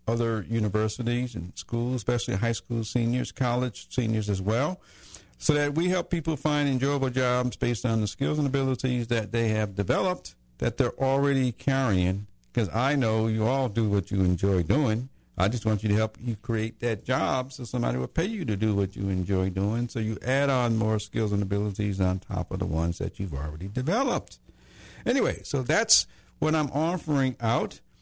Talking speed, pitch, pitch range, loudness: 190 wpm, 115 Hz, 100-130 Hz, -27 LUFS